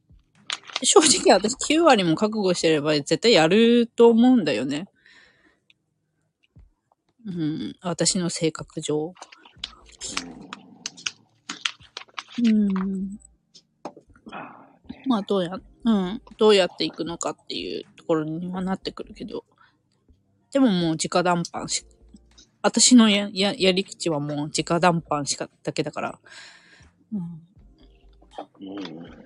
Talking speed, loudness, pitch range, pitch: 195 characters per minute, -22 LUFS, 160-225 Hz, 185 Hz